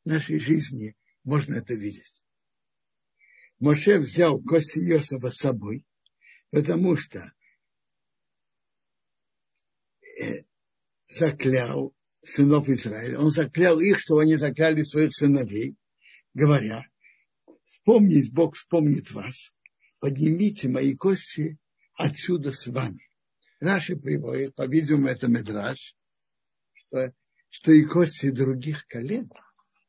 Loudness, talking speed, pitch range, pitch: -24 LUFS, 95 wpm, 130-165 Hz, 150 Hz